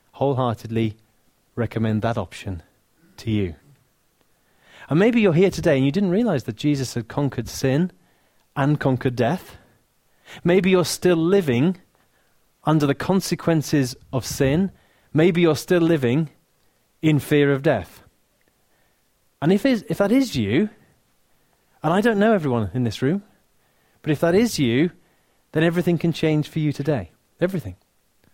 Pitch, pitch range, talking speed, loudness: 145 Hz, 120-175 Hz, 140 wpm, -21 LUFS